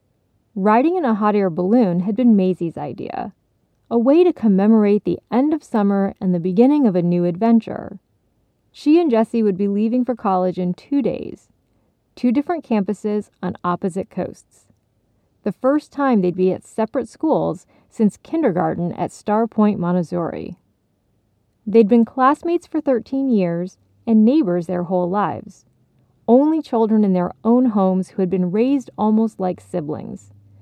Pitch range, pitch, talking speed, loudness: 180-240 Hz, 210 Hz, 155 wpm, -18 LUFS